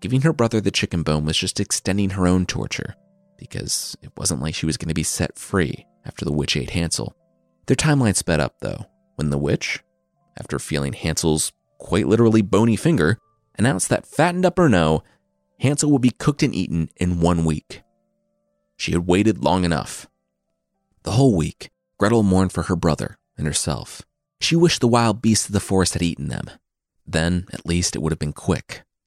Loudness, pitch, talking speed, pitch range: -21 LUFS, 95 Hz, 190 wpm, 80-120 Hz